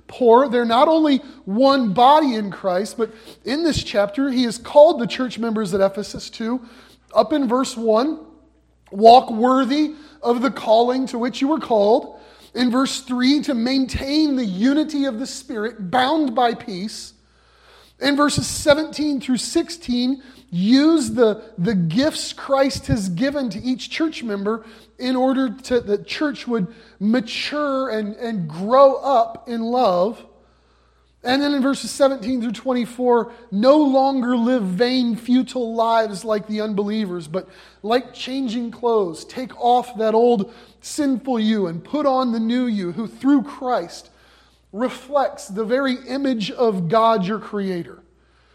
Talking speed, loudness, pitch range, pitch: 150 wpm, -19 LUFS, 220-270 Hz, 245 Hz